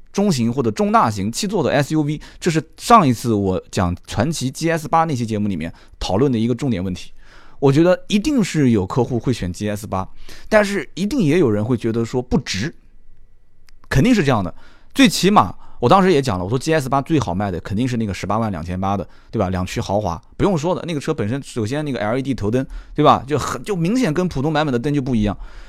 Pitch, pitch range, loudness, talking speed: 125 Hz, 105-160 Hz, -19 LUFS, 340 characters per minute